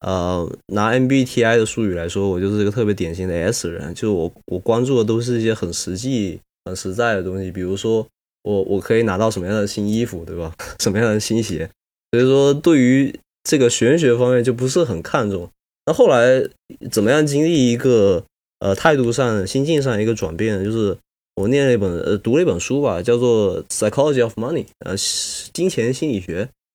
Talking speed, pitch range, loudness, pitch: 325 characters per minute, 95-125 Hz, -18 LUFS, 110 Hz